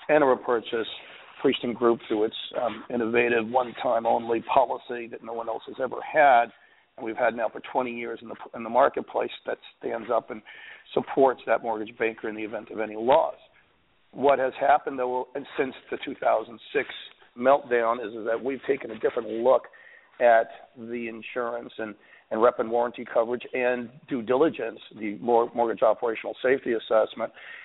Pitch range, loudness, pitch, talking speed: 115-125 Hz, -26 LUFS, 120 Hz, 165 wpm